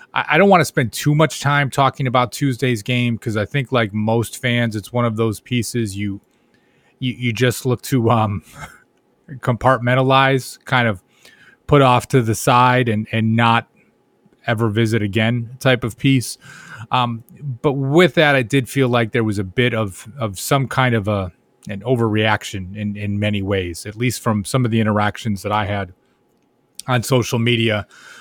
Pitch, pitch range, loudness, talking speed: 120 Hz, 110-130 Hz, -18 LUFS, 180 wpm